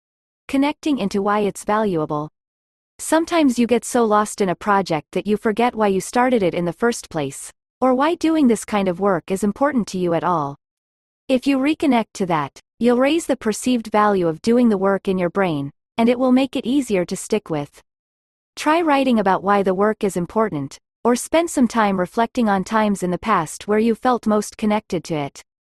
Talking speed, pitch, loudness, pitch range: 205 wpm, 210 Hz, -19 LUFS, 185-245 Hz